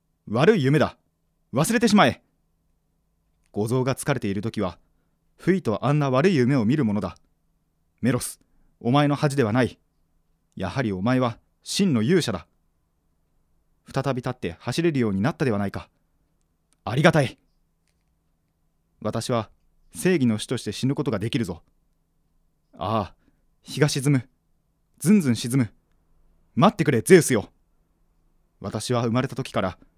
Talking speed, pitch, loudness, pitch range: 260 characters per minute, 115 Hz, -23 LUFS, 85-135 Hz